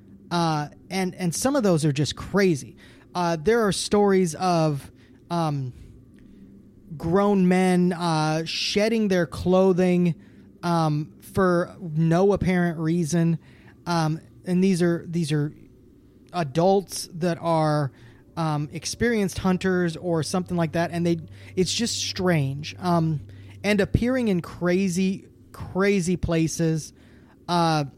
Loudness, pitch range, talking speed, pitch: -24 LUFS, 155-185 Hz, 120 wpm, 170 Hz